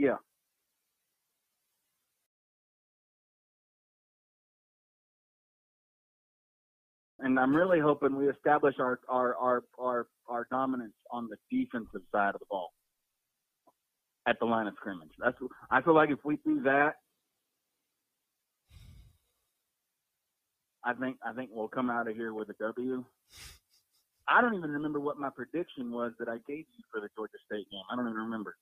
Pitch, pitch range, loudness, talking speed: 125 Hz, 115-145 Hz, -32 LUFS, 140 wpm